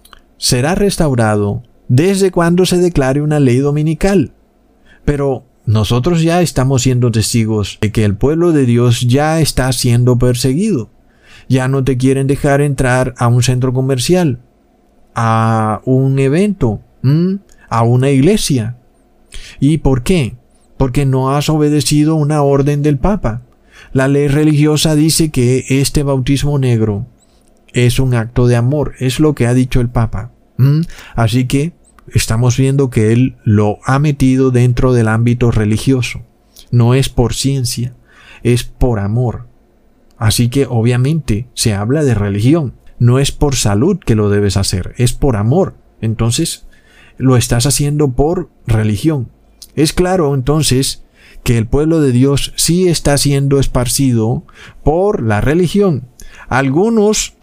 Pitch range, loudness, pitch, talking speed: 120-145 Hz, -13 LUFS, 130 Hz, 140 wpm